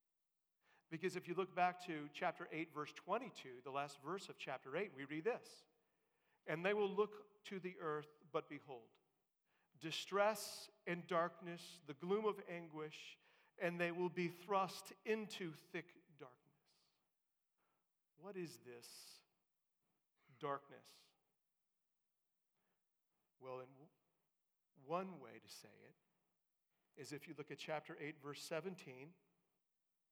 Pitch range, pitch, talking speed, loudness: 150-190 Hz, 170 Hz, 125 wpm, -46 LUFS